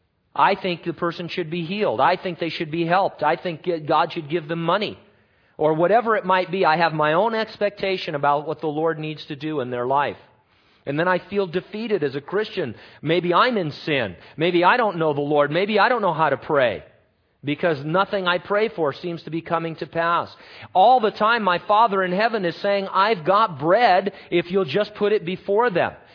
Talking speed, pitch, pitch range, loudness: 220 wpm, 175 Hz, 155-195 Hz, -21 LUFS